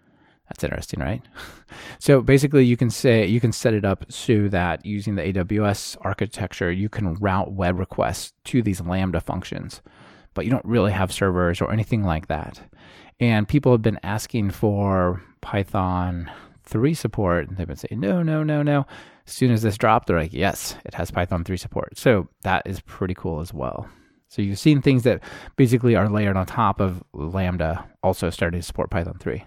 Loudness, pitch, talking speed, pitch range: -22 LUFS, 100 Hz, 190 wpm, 90-115 Hz